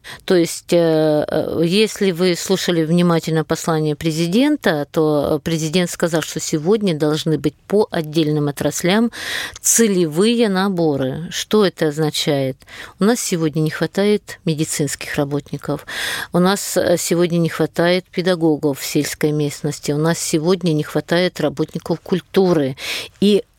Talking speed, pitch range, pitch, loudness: 120 wpm, 155-185 Hz, 165 Hz, -18 LUFS